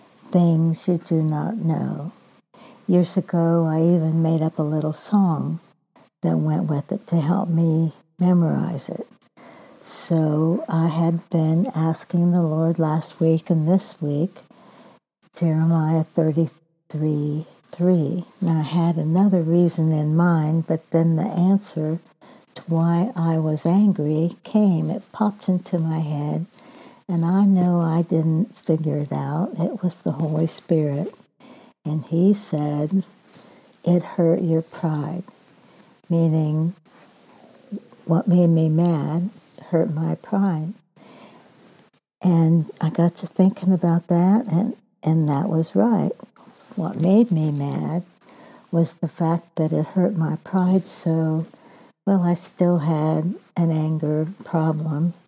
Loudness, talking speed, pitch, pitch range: -21 LUFS, 130 wpm, 170 Hz, 160-190 Hz